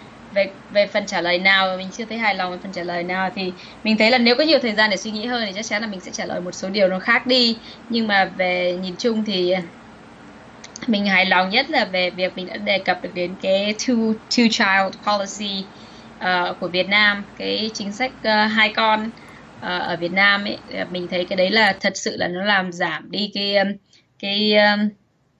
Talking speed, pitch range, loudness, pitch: 230 wpm, 185-220 Hz, -19 LUFS, 200 Hz